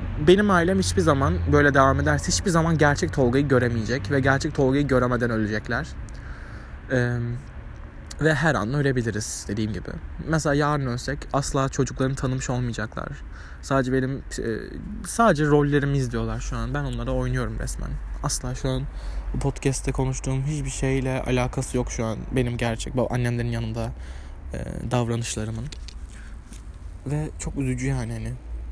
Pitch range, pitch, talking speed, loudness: 110-135 Hz, 125 Hz, 140 wpm, -24 LUFS